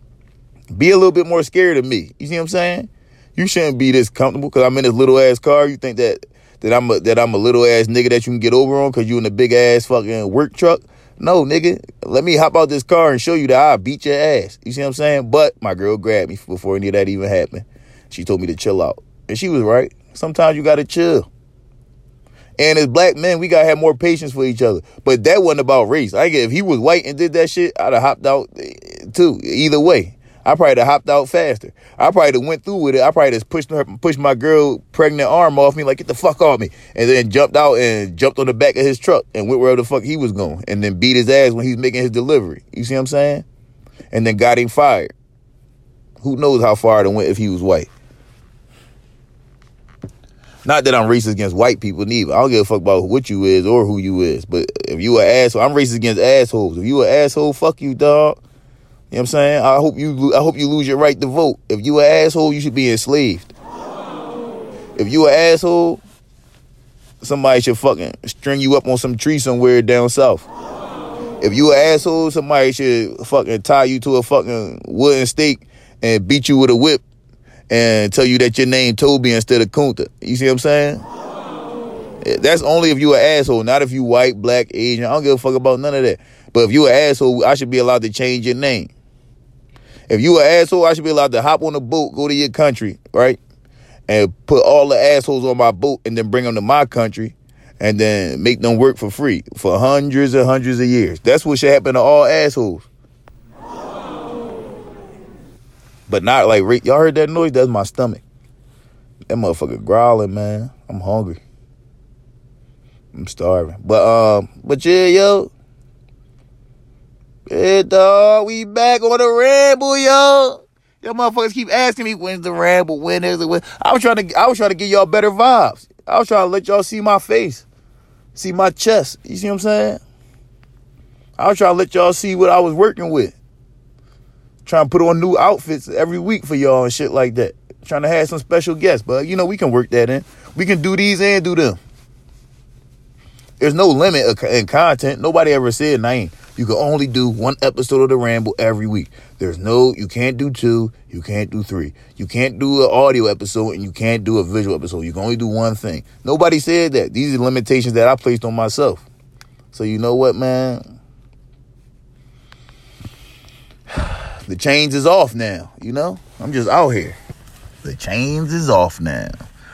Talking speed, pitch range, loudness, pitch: 220 wpm, 120-155 Hz, -14 LUFS, 130 Hz